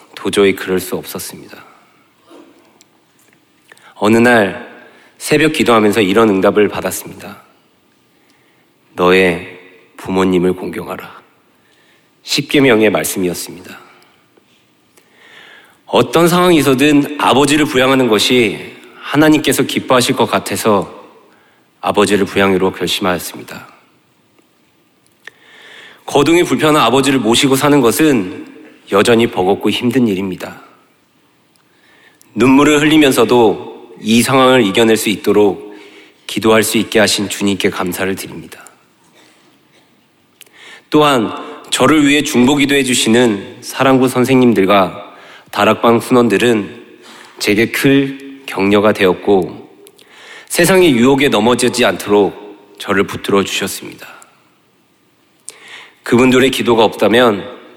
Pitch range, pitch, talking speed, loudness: 100-140 Hz, 120 Hz, 245 characters per minute, -12 LUFS